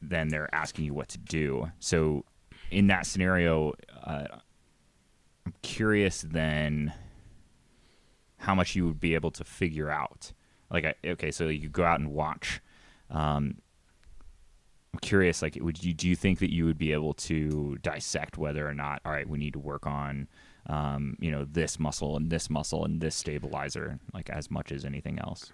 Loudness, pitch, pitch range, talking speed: -31 LUFS, 75 Hz, 75-85 Hz, 180 wpm